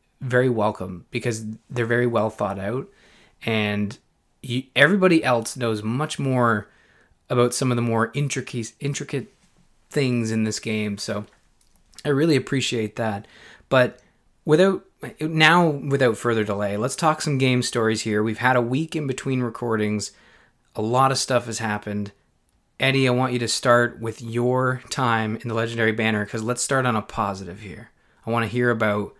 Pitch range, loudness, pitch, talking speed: 110-130 Hz, -22 LUFS, 120 Hz, 165 wpm